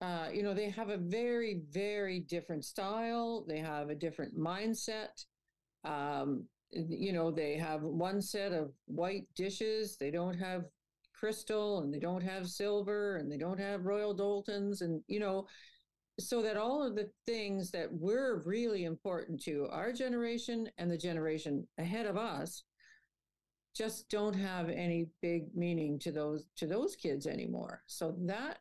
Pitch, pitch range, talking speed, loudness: 195 Hz, 165-215 Hz, 160 wpm, -38 LUFS